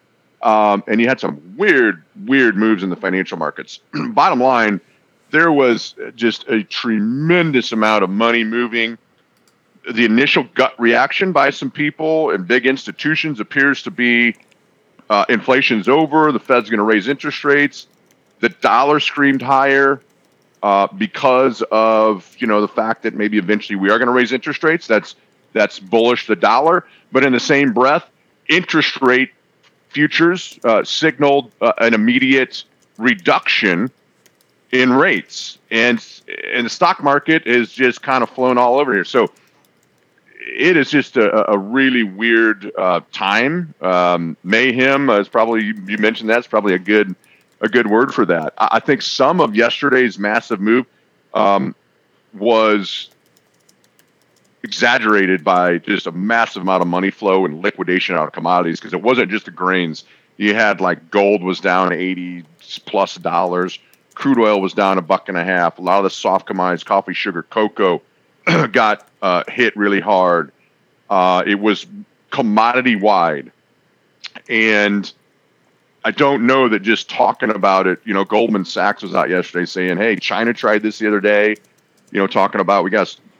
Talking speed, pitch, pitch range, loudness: 160 wpm, 115 Hz, 100-130 Hz, -15 LUFS